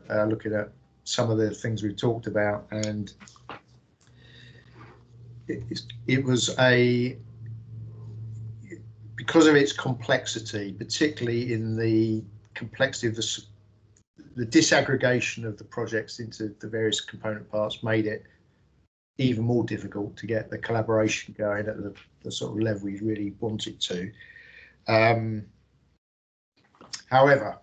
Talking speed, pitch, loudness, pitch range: 125 wpm, 110 Hz, -26 LUFS, 105-120 Hz